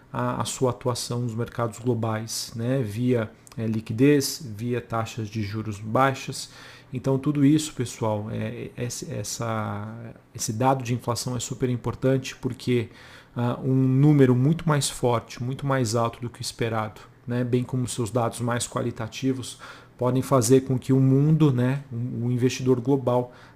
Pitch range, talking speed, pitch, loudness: 115-130 Hz, 160 wpm, 125 Hz, -25 LUFS